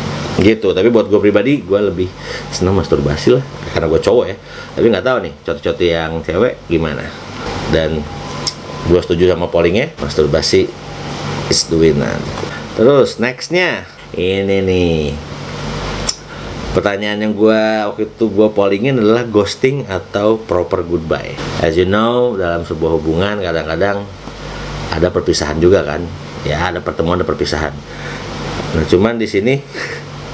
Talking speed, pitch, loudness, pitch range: 135 wpm, 95 Hz, -15 LUFS, 80-110 Hz